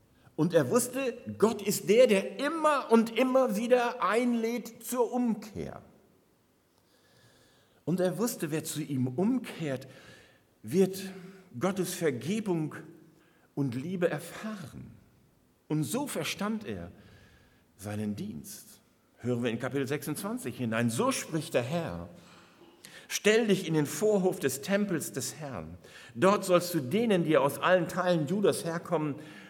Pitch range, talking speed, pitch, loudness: 140-215 Hz, 125 wpm, 175 Hz, -30 LUFS